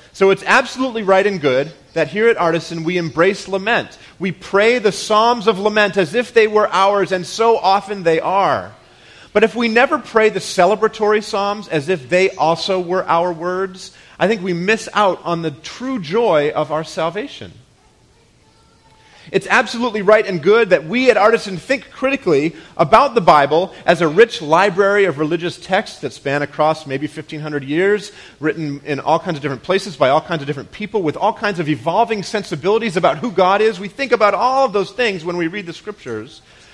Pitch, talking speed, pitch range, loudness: 195 Hz, 195 wpm, 165-220 Hz, -16 LUFS